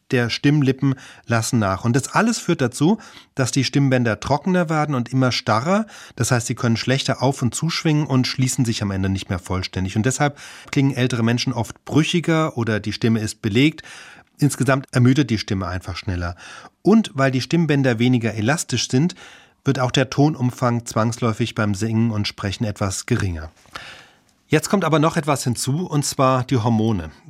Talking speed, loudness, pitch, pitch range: 175 wpm, -20 LUFS, 130 Hz, 115-145 Hz